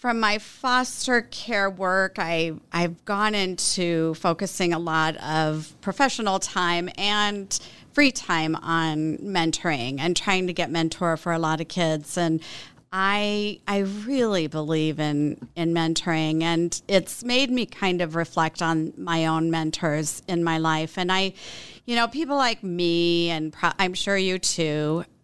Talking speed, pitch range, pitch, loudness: 155 wpm, 160-195 Hz, 170 Hz, -24 LUFS